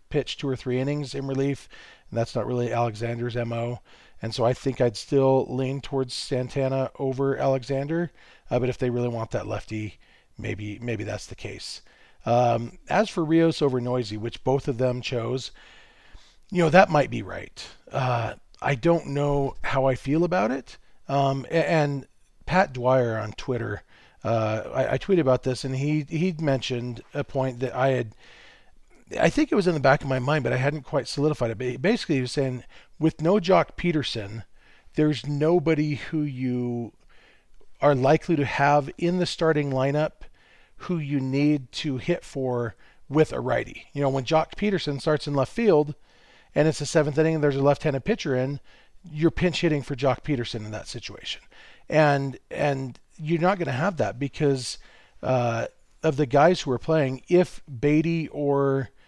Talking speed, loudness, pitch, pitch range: 180 wpm, -25 LUFS, 135 Hz, 125-155 Hz